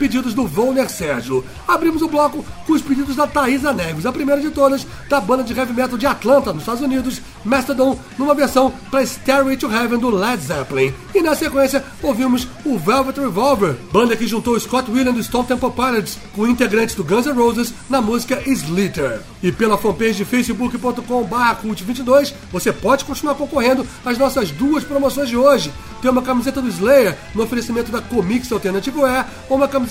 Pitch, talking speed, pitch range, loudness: 255 Hz, 185 wpm, 230-275 Hz, -17 LUFS